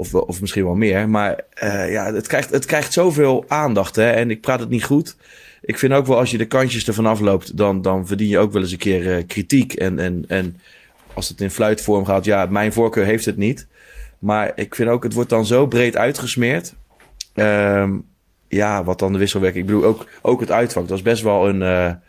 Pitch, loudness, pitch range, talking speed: 105 Hz, -18 LUFS, 95-115 Hz, 230 wpm